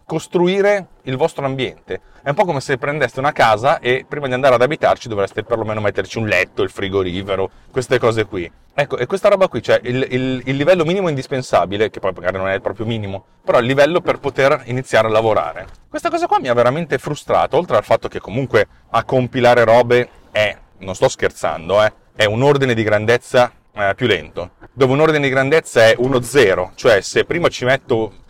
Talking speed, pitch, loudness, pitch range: 200 wpm, 125 Hz, -16 LUFS, 110-140 Hz